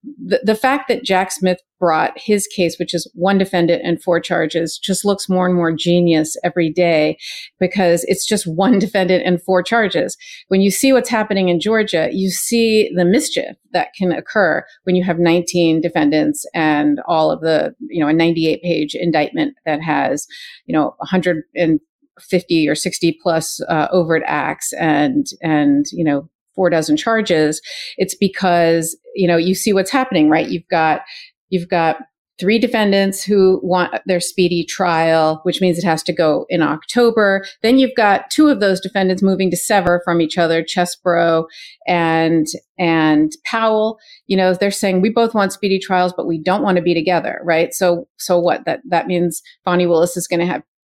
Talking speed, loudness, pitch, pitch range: 180 wpm, -16 LUFS, 180 Hz, 165-200 Hz